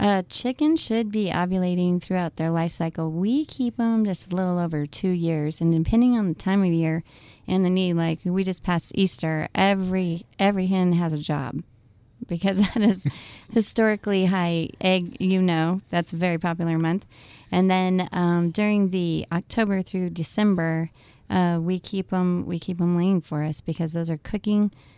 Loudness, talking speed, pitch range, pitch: -24 LUFS, 180 wpm, 165-195 Hz, 180 Hz